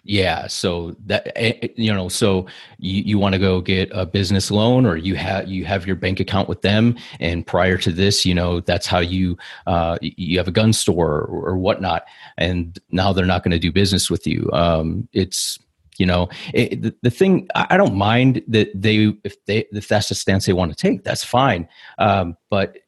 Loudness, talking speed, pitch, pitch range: -19 LUFS, 205 wpm, 95 Hz, 90-105 Hz